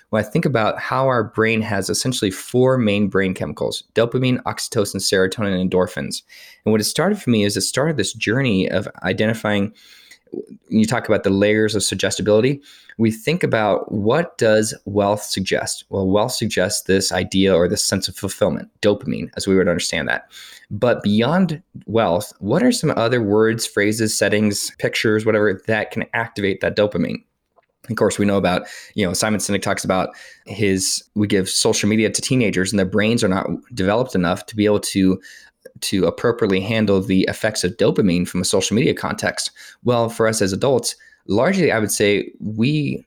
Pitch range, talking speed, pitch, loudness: 95-115 Hz, 180 wpm, 105 Hz, -19 LUFS